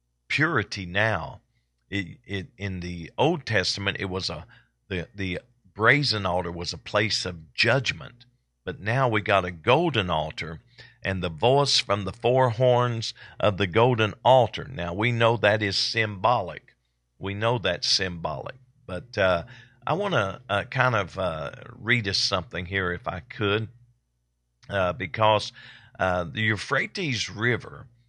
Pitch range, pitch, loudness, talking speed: 90-120 Hz, 105 Hz, -25 LUFS, 150 wpm